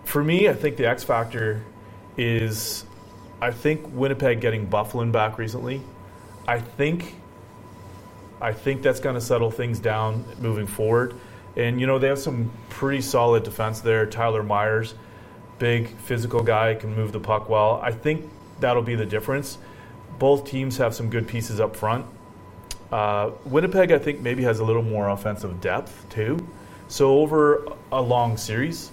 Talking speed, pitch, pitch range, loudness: 160 wpm, 115 Hz, 110-130 Hz, -23 LUFS